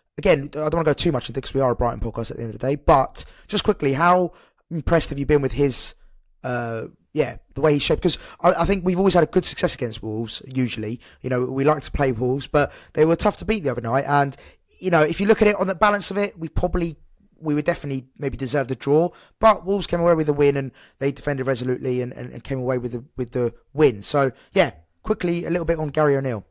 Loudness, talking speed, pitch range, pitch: -22 LUFS, 270 wpm, 130-170 Hz, 145 Hz